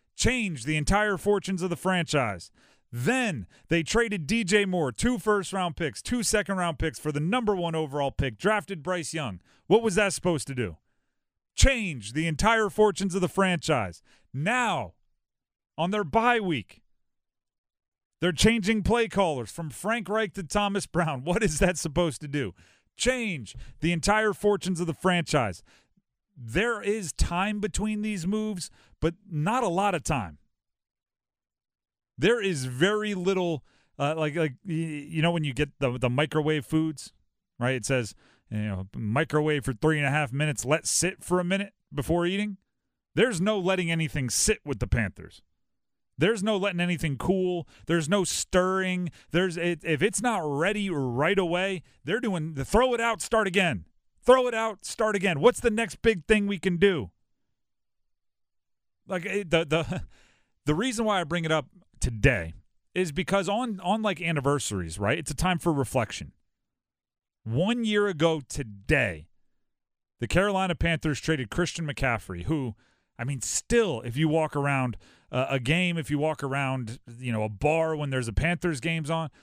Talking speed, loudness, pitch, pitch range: 165 wpm, -27 LUFS, 165 Hz, 135-200 Hz